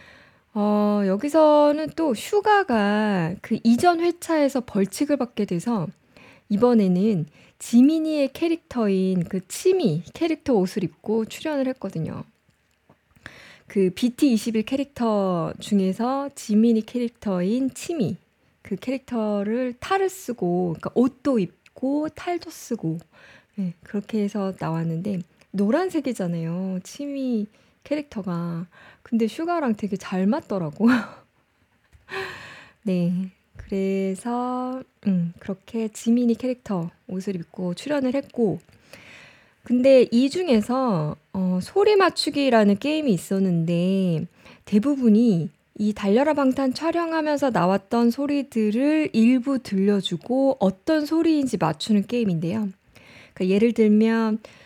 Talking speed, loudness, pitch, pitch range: 240 characters per minute, -23 LUFS, 220 Hz, 190-270 Hz